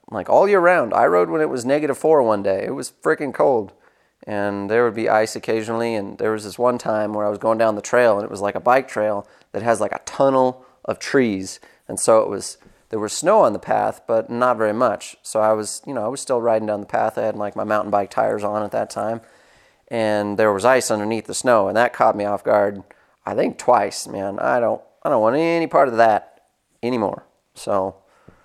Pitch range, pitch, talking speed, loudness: 105-120 Hz, 110 Hz, 245 wpm, -20 LUFS